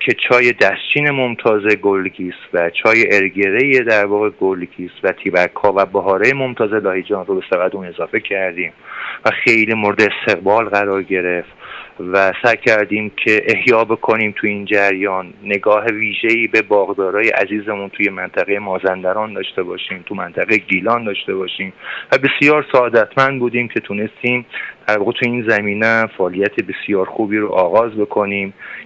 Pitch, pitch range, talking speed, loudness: 105 Hz, 95-115 Hz, 145 wpm, -15 LUFS